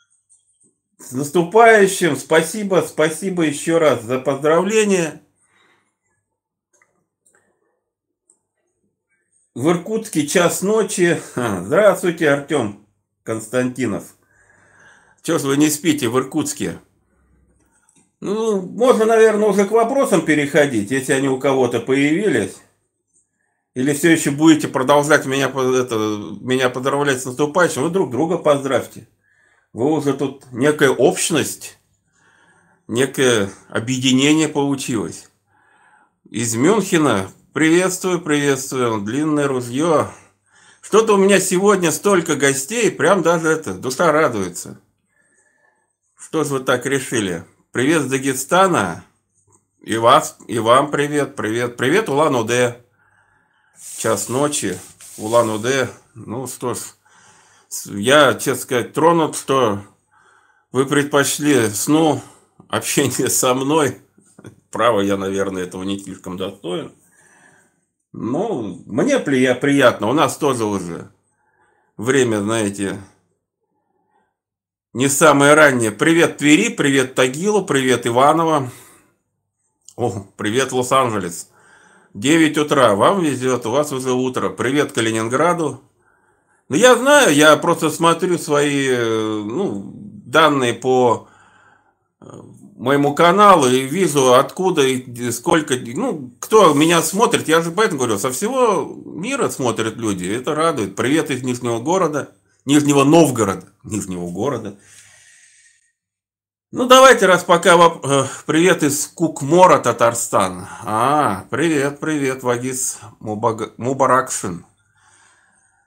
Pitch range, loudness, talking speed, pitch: 120-165 Hz, -16 LUFS, 100 wpm, 140 Hz